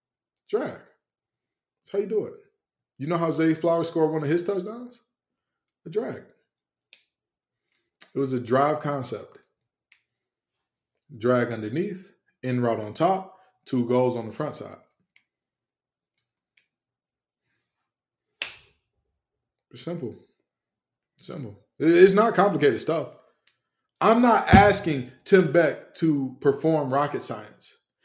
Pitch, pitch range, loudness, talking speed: 160 Hz, 135-195 Hz, -24 LUFS, 110 wpm